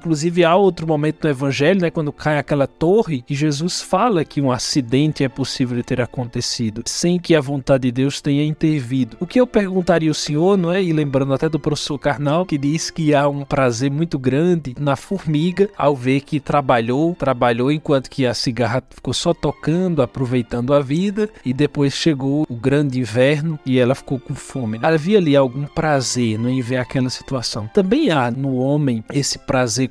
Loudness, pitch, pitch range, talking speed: -18 LUFS, 145 Hz, 130-160 Hz, 195 wpm